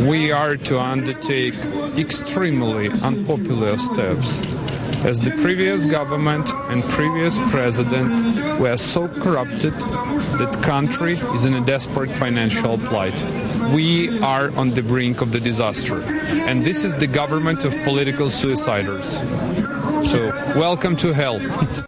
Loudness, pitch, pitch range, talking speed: -19 LUFS, 135 Hz, 125-150 Hz, 125 wpm